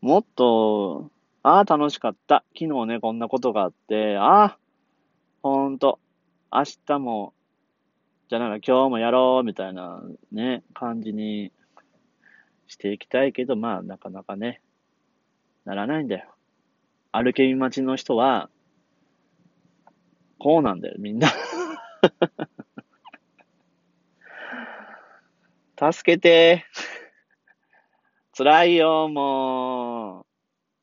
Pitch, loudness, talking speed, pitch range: 130 Hz, -22 LUFS, 185 characters per minute, 115-150 Hz